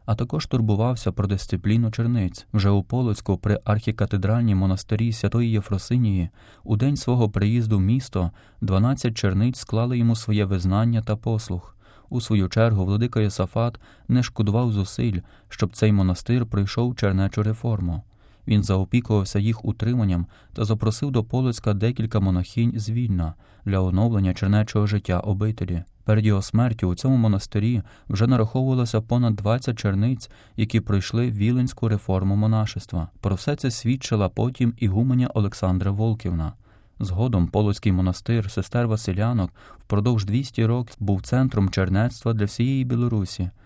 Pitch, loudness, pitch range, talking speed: 110 Hz, -23 LUFS, 100-115 Hz, 135 wpm